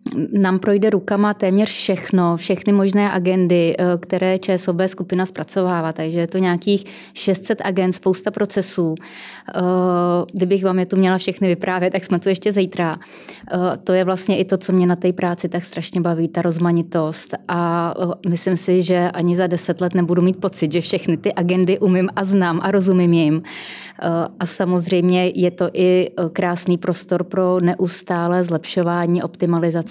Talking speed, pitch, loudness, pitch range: 160 wpm, 180 Hz, -18 LUFS, 175-190 Hz